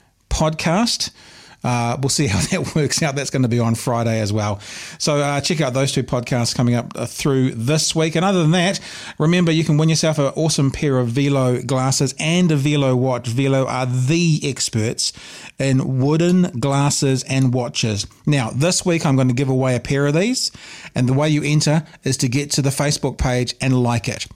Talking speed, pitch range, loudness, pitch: 205 wpm, 125-155 Hz, -18 LUFS, 140 Hz